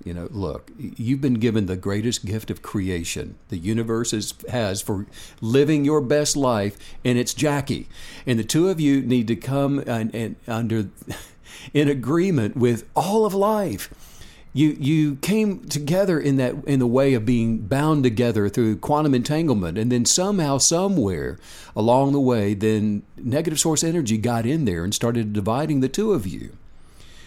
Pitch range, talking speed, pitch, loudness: 110-150 Hz, 170 wpm, 125 Hz, -22 LUFS